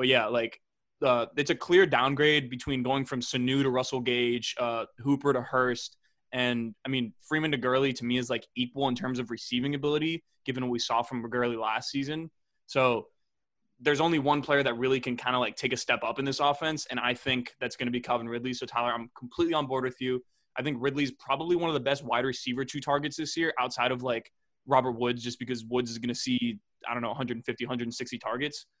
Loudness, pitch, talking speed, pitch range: -29 LUFS, 130 Hz, 230 wpm, 120-145 Hz